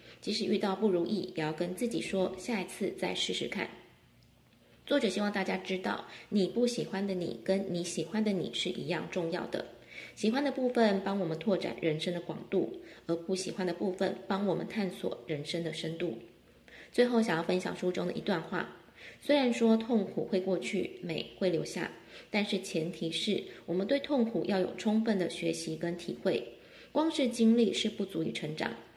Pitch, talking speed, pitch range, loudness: 190 Hz, 275 characters per minute, 170-220 Hz, -33 LUFS